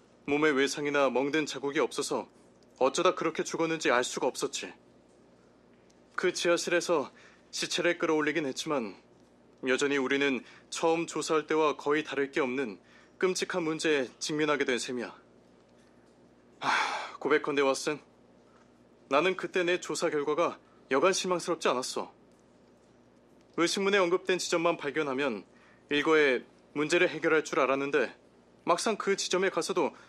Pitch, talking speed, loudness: 145 Hz, 285 characters per minute, -29 LUFS